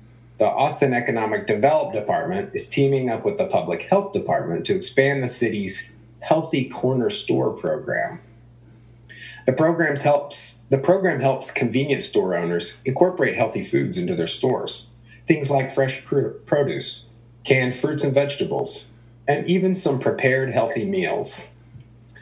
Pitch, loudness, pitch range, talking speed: 130 Hz, -22 LUFS, 120-140 Hz, 140 wpm